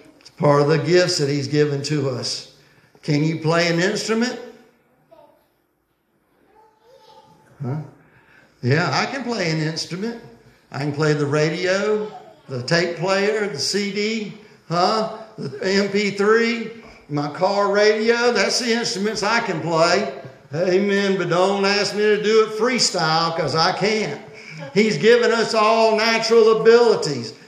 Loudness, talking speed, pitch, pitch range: -19 LUFS, 135 wpm, 195 Hz, 155-220 Hz